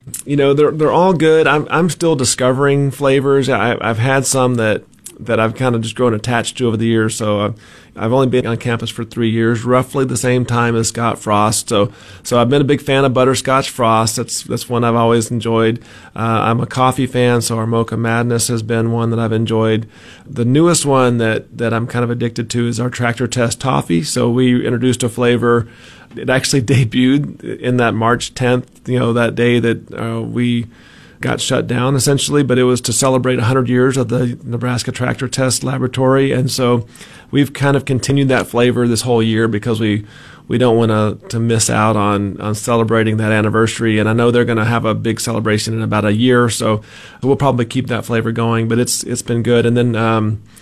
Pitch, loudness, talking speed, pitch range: 120 Hz, -15 LUFS, 215 wpm, 115-130 Hz